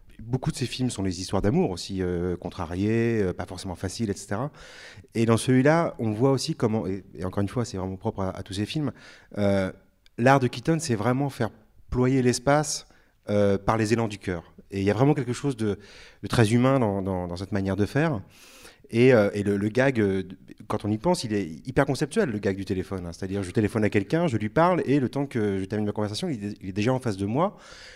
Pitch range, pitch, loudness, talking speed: 100-130 Hz, 110 Hz, -26 LUFS, 245 wpm